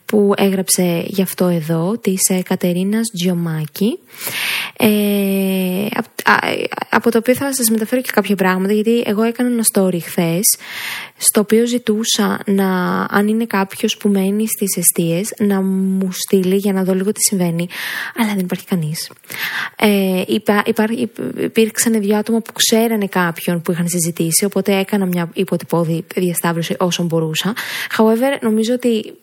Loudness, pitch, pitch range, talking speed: -16 LUFS, 195 Hz, 185-220 Hz, 145 wpm